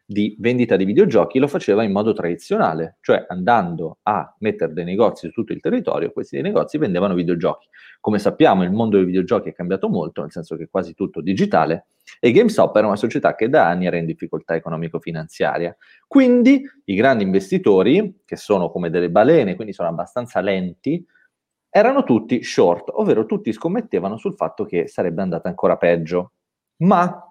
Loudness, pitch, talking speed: -19 LUFS, 95 Hz, 170 wpm